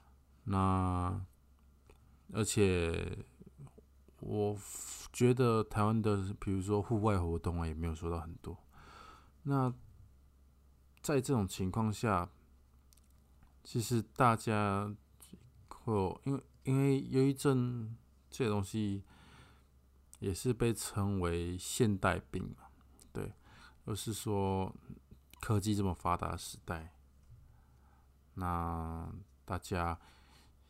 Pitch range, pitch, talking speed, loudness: 70-105 Hz, 90 Hz, 140 characters per minute, -35 LUFS